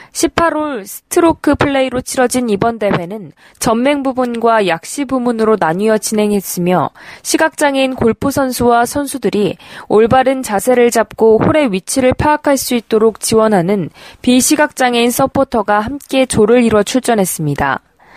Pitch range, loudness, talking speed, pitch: 210-270 Hz, -13 LUFS, 315 characters per minute, 240 Hz